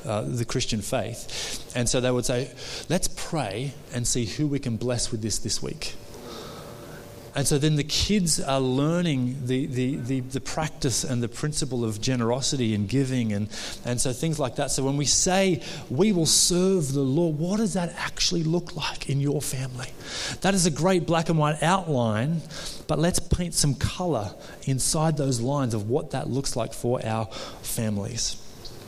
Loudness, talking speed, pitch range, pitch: -25 LUFS, 185 wpm, 120-160 Hz, 135 Hz